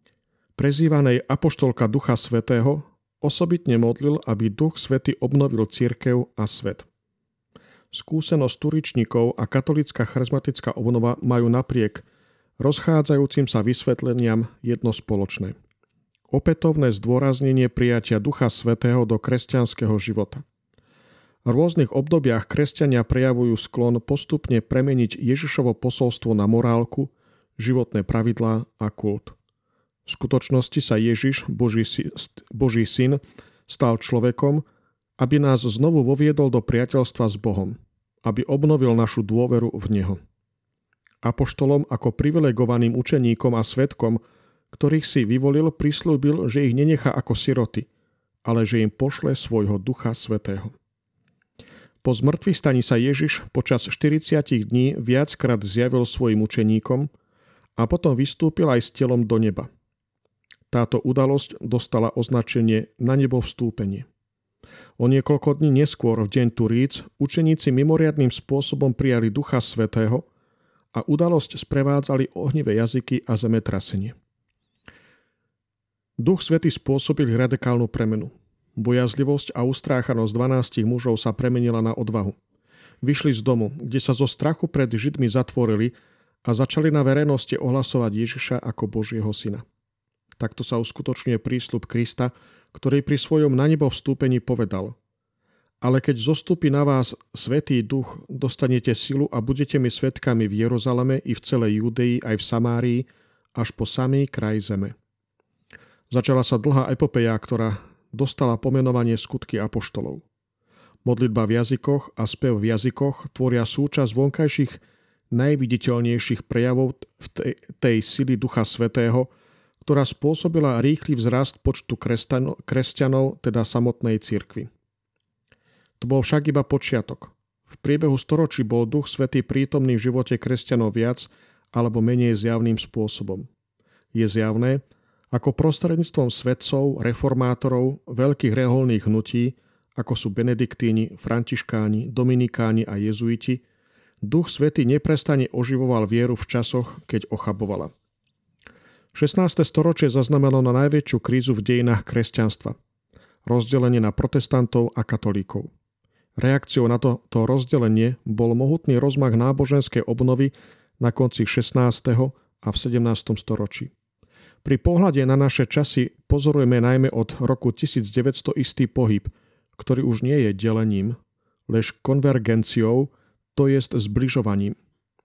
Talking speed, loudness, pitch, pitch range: 120 wpm, -22 LUFS, 125 Hz, 115-140 Hz